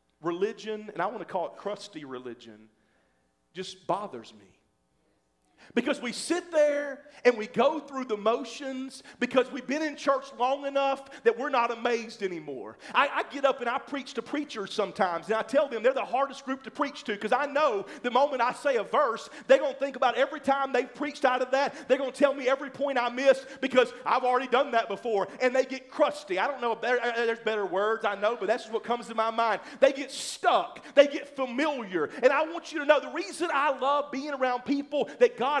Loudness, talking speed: -28 LUFS, 220 wpm